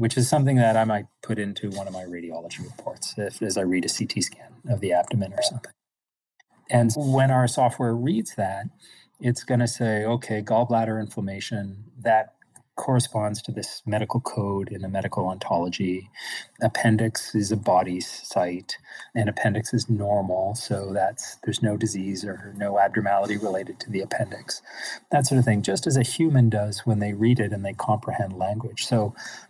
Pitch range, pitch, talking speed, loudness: 100-120 Hz, 110 Hz, 175 wpm, -25 LUFS